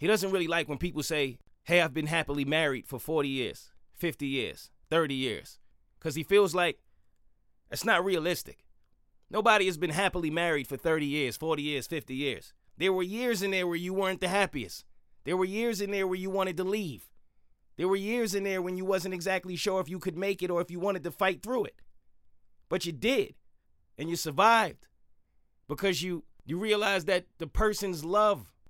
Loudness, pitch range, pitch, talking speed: -30 LUFS, 145-195 Hz, 175 Hz, 200 wpm